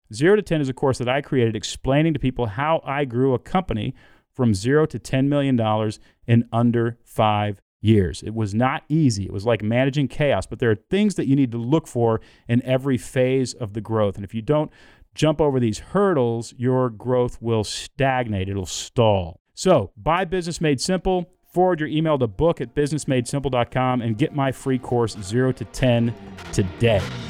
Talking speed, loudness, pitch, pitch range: 190 wpm, -22 LUFS, 125 Hz, 115-145 Hz